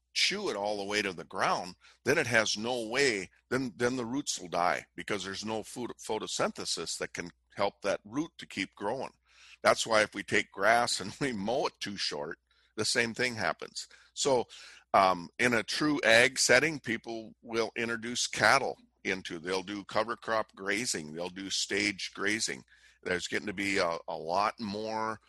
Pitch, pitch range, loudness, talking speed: 110 Hz, 100-115 Hz, -30 LUFS, 185 wpm